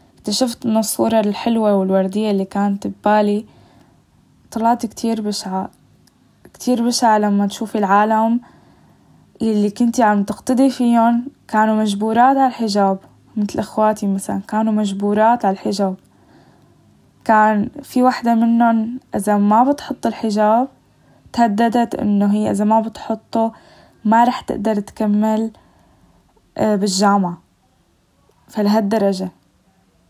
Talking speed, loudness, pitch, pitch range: 105 wpm, -17 LUFS, 215 Hz, 205-230 Hz